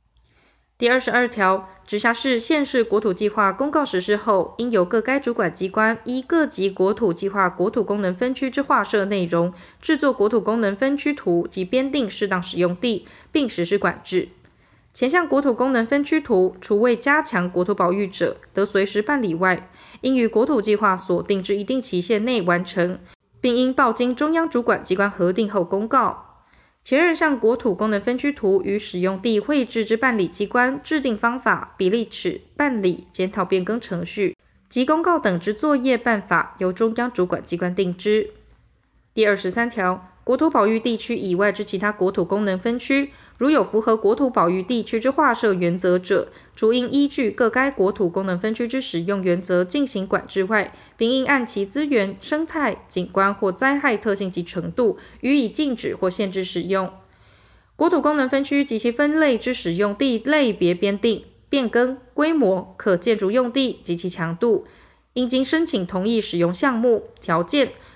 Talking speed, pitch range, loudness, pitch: 270 characters per minute, 190-260 Hz, -21 LUFS, 220 Hz